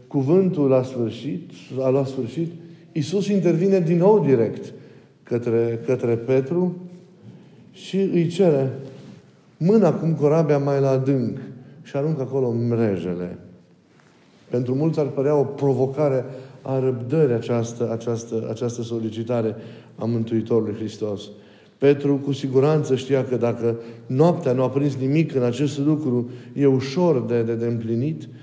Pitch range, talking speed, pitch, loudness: 115-150 Hz, 130 wpm, 130 Hz, -22 LUFS